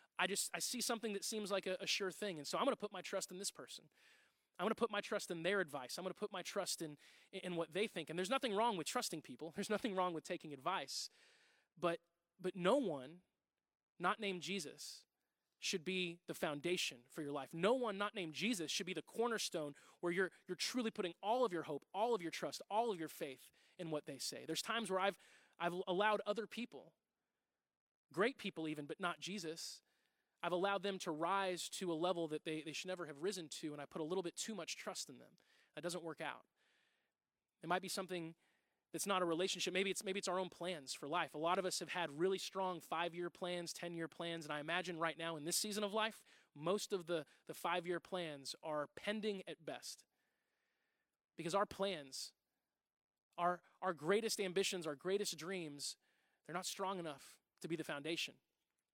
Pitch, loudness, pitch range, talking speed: 180 Hz, -42 LUFS, 165-200 Hz, 220 wpm